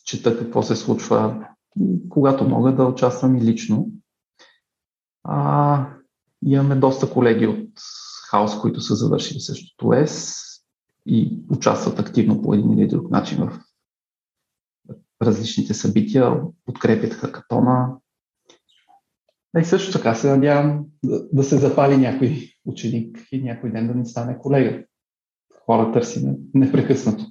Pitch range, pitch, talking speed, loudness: 120-145 Hz, 130 Hz, 125 wpm, -20 LUFS